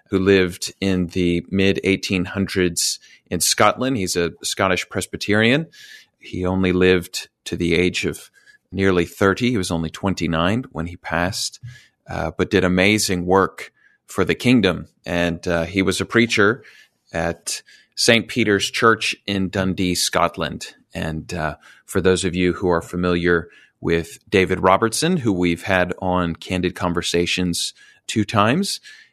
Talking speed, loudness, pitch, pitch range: 140 wpm, -20 LUFS, 95 Hz, 85-100 Hz